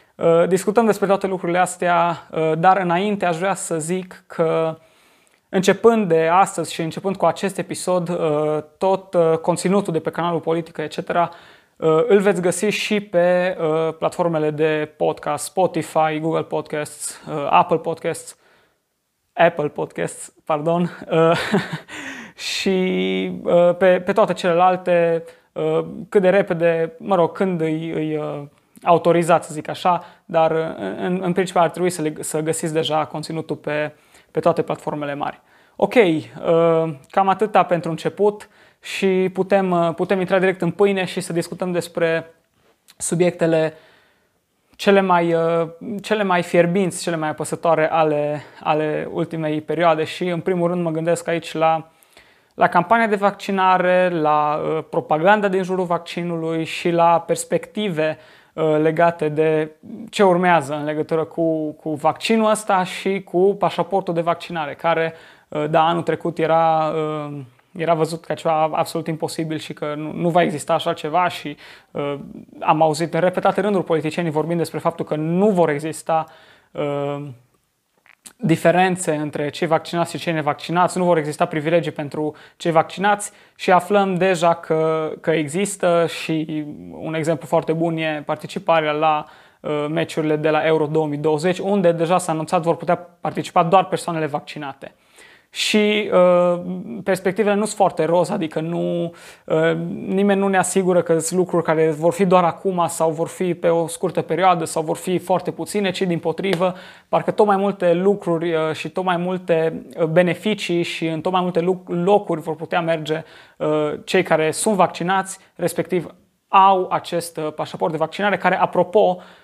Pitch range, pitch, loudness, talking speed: 160-185 Hz, 170 Hz, -20 LUFS, 145 wpm